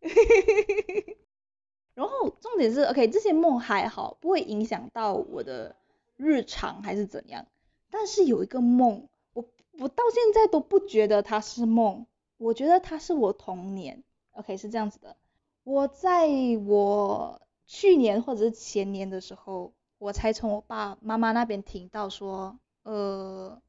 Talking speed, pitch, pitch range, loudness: 230 characters per minute, 230 Hz, 205-335 Hz, -26 LUFS